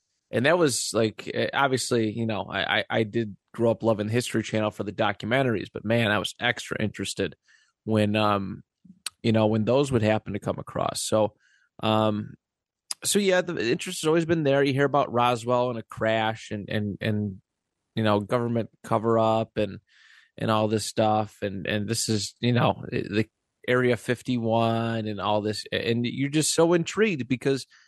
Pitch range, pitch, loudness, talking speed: 105-125 Hz, 115 Hz, -25 LUFS, 180 wpm